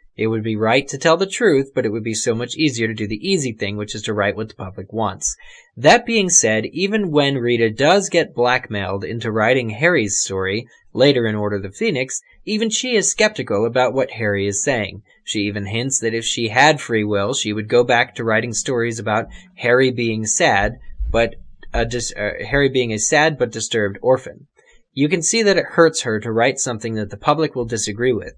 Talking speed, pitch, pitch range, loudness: 220 wpm, 115 Hz, 110-145 Hz, -18 LUFS